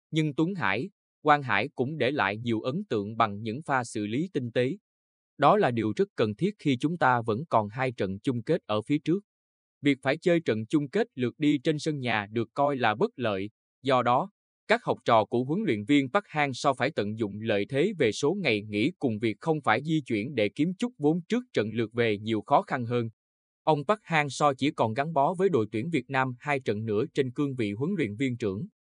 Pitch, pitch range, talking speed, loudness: 130 Hz, 110-155 Hz, 235 wpm, -28 LUFS